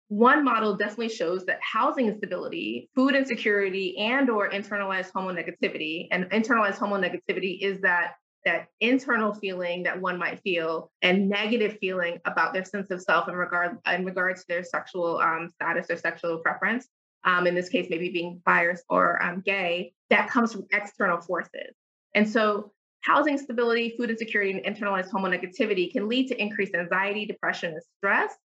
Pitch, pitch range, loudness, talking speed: 195 Hz, 180-220 Hz, -26 LUFS, 170 wpm